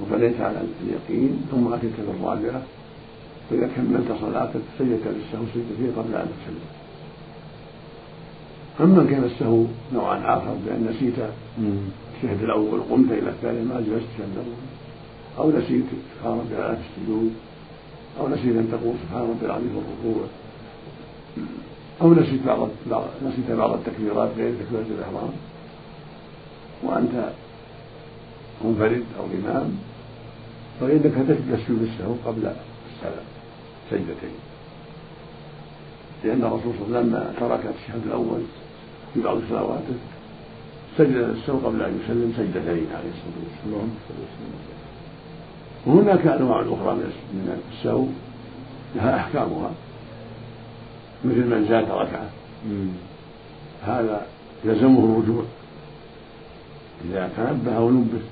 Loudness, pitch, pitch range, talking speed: -23 LUFS, 115 Hz, 110-120 Hz, 105 wpm